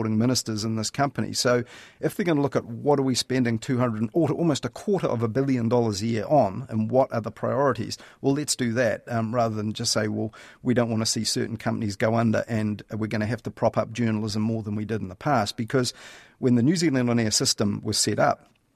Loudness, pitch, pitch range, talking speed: -25 LUFS, 115 Hz, 110-130 Hz, 250 wpm